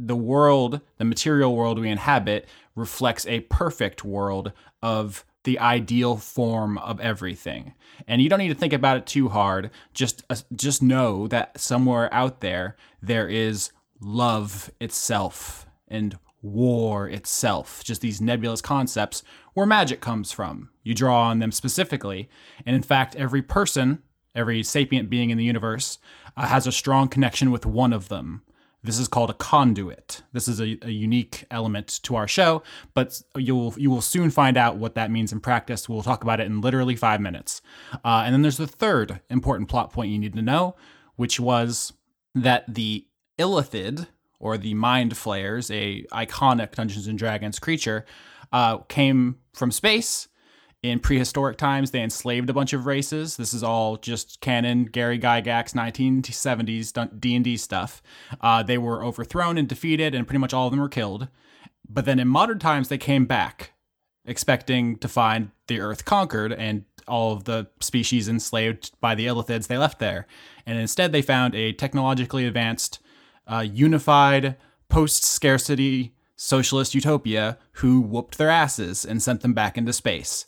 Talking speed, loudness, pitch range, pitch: 165 wpm, -23 LUFS, 110-135 Hz, 120 Hz